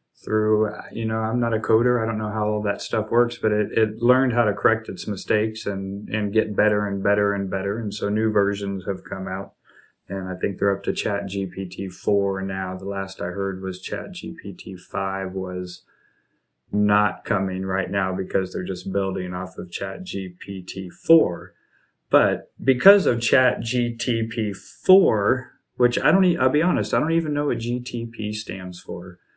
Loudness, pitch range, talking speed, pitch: -23 LUFS, 95-115 Hz, 180 wpm, 105 Hz